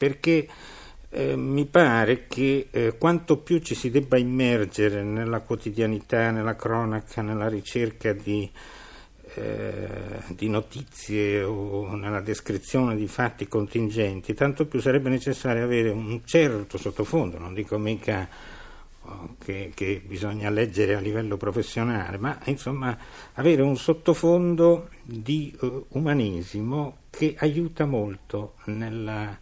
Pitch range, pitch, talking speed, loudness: 105-135 Hz, 115 Hz, 120 wpm, -25 LUFS